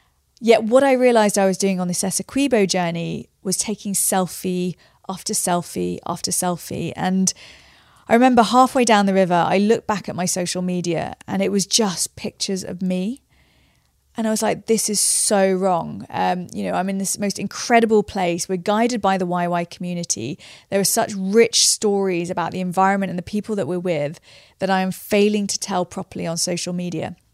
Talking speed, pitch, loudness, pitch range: 190 wpm, 190 Hz, -20 LUFS, 180-210 Hz